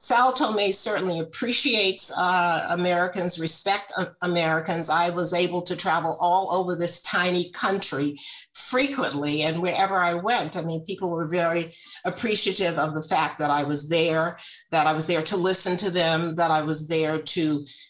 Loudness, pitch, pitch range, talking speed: -20 LUFS, 175 Hz, 160-190 Hz, 170 wpm